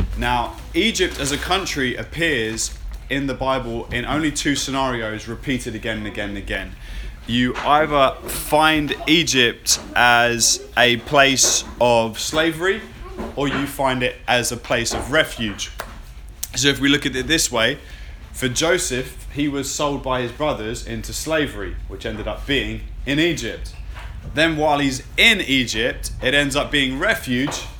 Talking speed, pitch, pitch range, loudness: 155 wpm, 125 Hz, 110-140 Hz, -19 LUFS